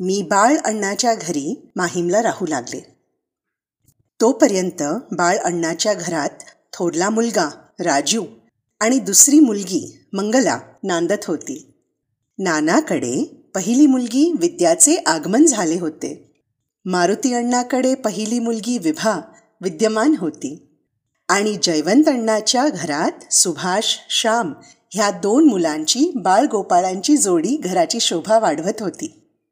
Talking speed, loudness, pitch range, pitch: 100 wpm, -17 LUFS, 185-300 Hz, 225 Hz